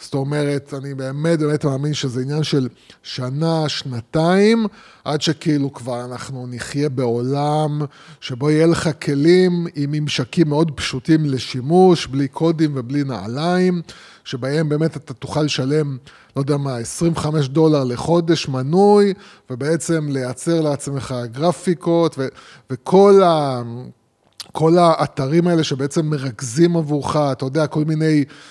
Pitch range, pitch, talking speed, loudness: 135-165 Hz, 150 Hz, 125 wpm, -18 LUFS